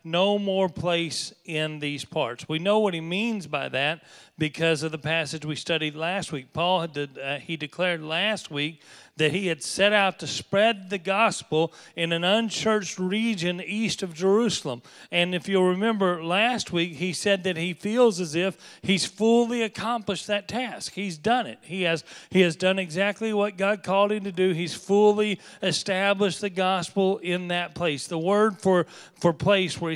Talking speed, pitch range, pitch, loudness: 185 wpm, 165-205 Hz, 185 Hz, -25 LUFS